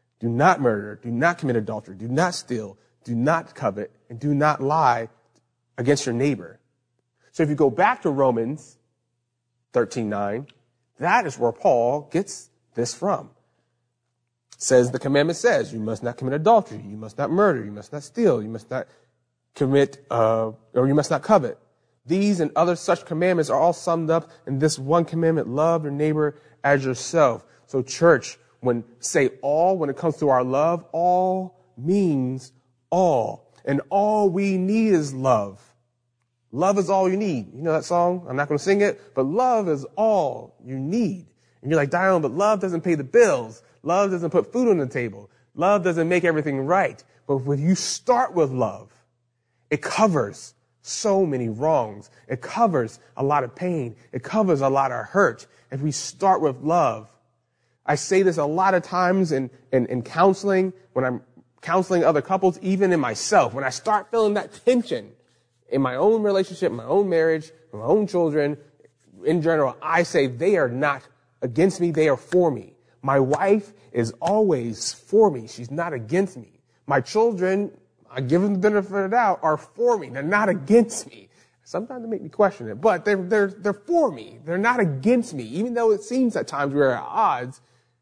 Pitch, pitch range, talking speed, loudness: 150 Hz, 125-185 Hz, 185 wpm, -22 LUFS